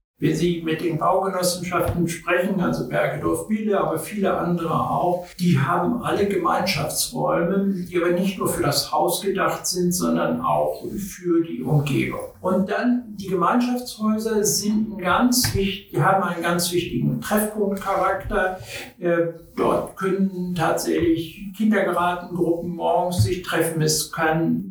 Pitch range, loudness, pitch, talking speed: 170-195 Hz, -22 LUFS, 175 Hz, 130 wpm